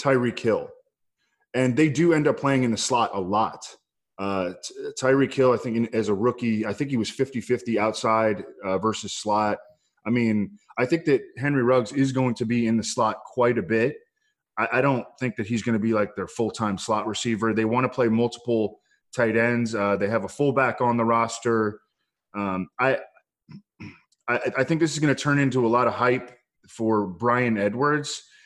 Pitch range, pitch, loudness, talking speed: 110-135 Hz, 120 Hz, -24 LUFS, 205 wpm